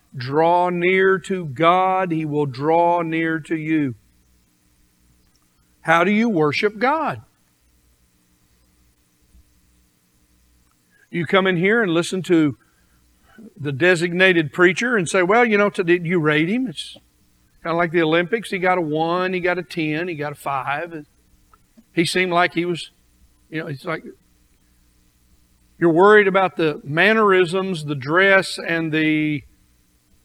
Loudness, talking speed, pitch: -19 LUFS, 140 wpm, 160 Hz